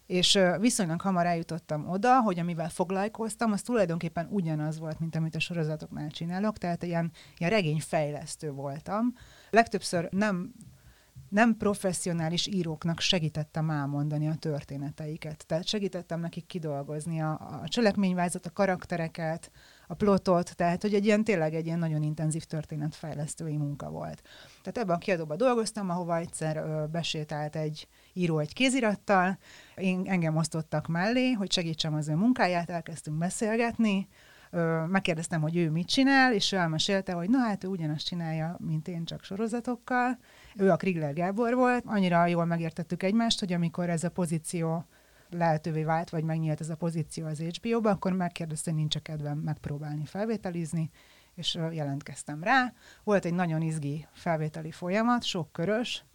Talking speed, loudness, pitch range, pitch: 145 wpm, -29 LUFS, 155-195 Hz, 170 Hz